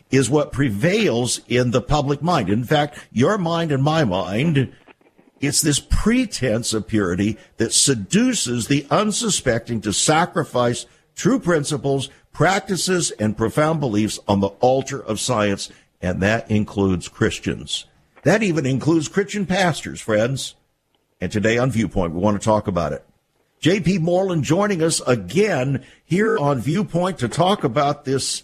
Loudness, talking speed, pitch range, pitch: -20 LUFS, 145 wpm, 110-165 Hz, 135 Hz